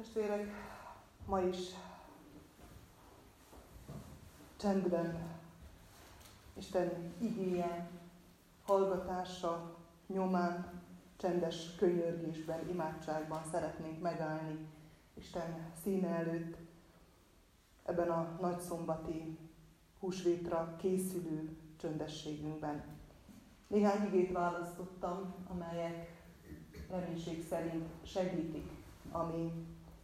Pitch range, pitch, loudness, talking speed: 160-180 Hz, 170 Hz, -39 LUFS, 60 wpm